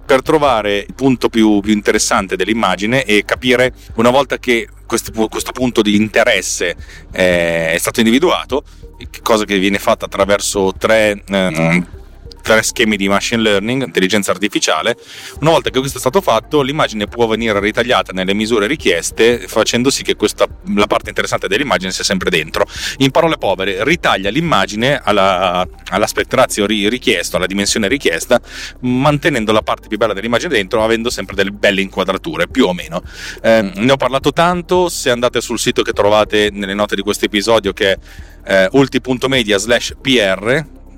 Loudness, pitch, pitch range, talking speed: -14 LUFS, 105 Hz, 100-125 Hz, 160 wpm